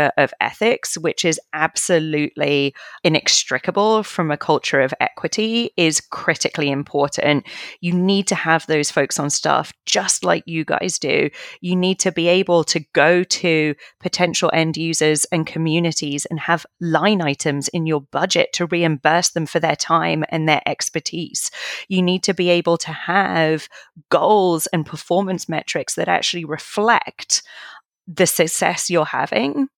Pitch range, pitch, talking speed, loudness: 155-180 Hz, 165 Hz, 150 wpm, -18 LUFS